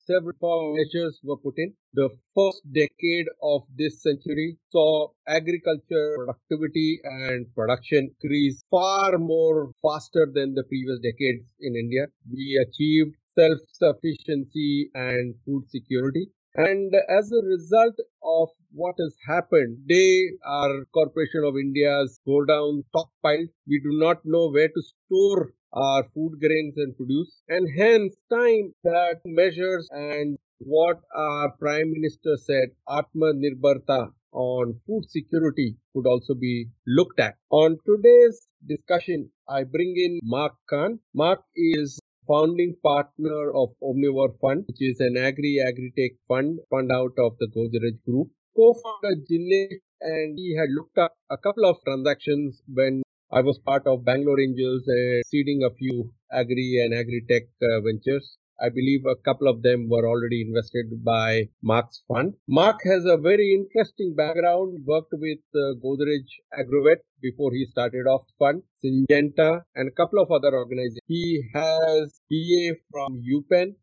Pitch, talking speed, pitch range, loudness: 150 Hz, 145 wpm, 130-170 Hz, -23 LUFS